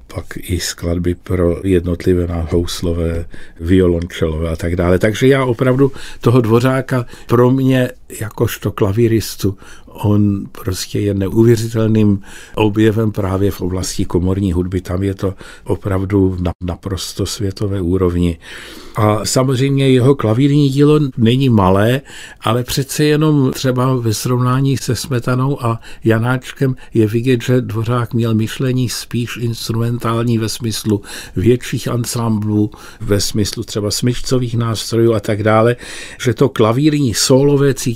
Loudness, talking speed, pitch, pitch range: -15 LUFS, 120 wpm, 110 Hz, 95-125 Hz